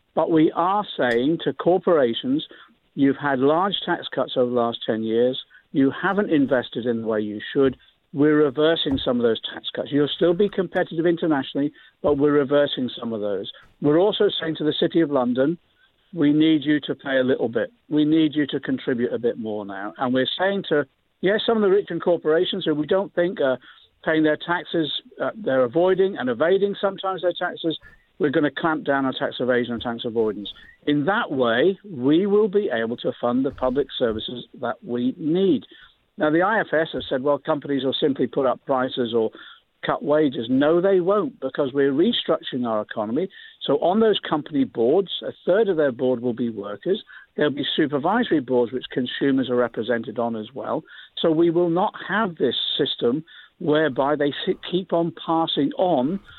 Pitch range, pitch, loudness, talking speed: 130-175 Hz, 150 Hz, -22 LUFS, 190 wpm